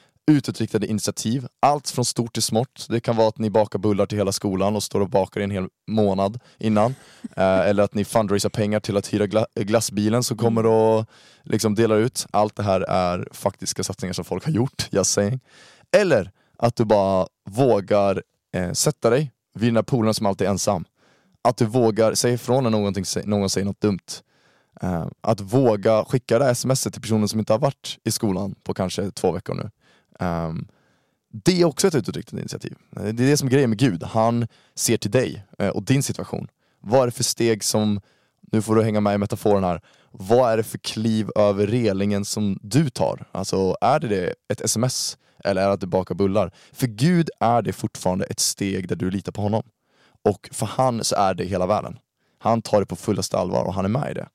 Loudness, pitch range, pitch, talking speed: -22 LUFS, 100-120 Hz, 110 Hz, 205 wpm